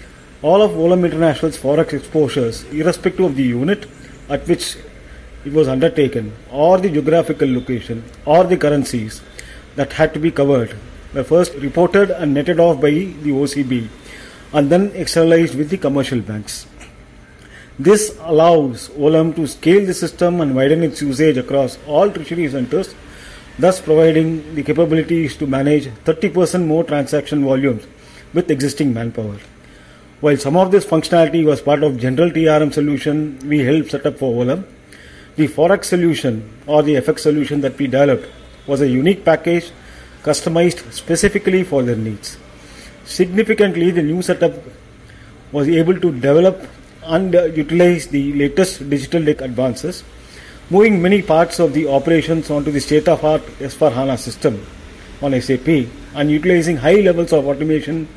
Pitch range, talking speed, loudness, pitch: 135-170 Hz, 150 wpm, -16 LUFS, 150 Hz